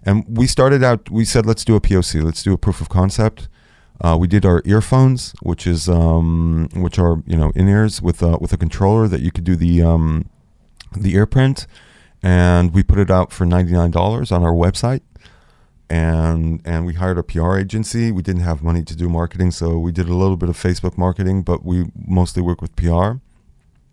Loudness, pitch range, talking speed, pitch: -17 LUFS, 85-100 Hz, 205 wpm, 90 Hz